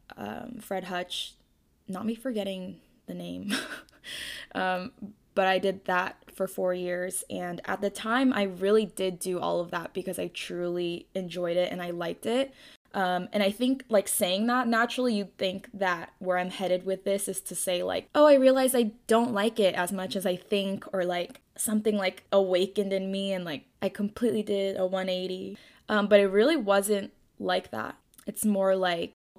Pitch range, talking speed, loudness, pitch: 185-215 Hz, 190 wpm, -28 LUFS, 195 Hz